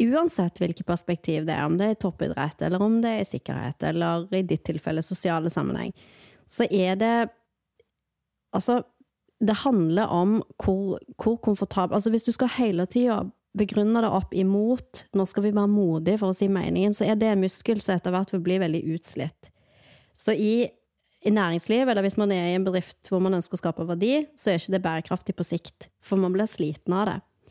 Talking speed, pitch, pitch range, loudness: 205 wpm, 190 Hz, 175-215 Hz, -25 LUFS